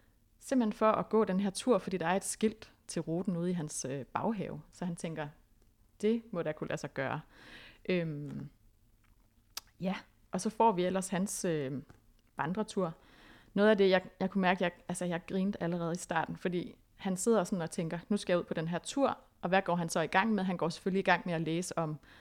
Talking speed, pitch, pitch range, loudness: 225 wpm, 180 Hz, 160-195 Hz, -33 LUFS